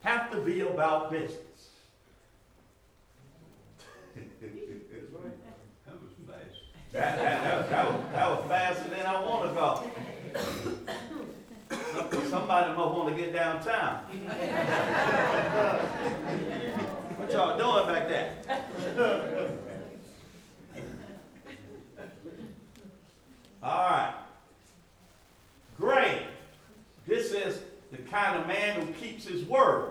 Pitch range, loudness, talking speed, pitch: 175-230 Hz, -30 LUFS, 80 wpm, 190 Hz